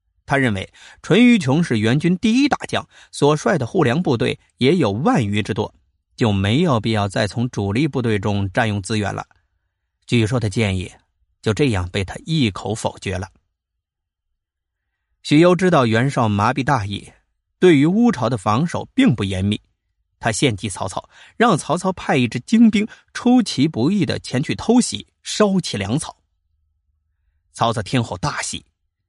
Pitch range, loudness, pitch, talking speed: 90-145 Hz, -19 LUFS, 110 Hz, 230 characters per minute